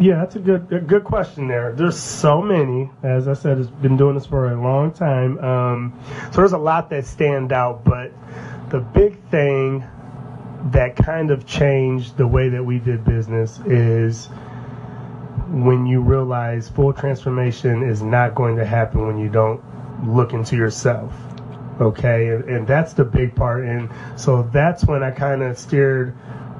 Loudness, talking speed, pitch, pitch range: -19 LUFS, 170 wpm, 130 Hz, 120-140 Hz